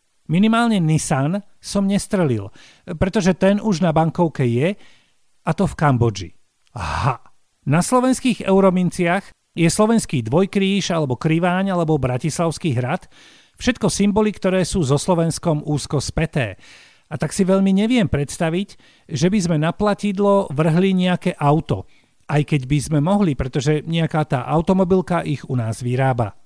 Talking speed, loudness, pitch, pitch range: 140 wpm, -19 LUFS, 170 Hz, 150-195 Hz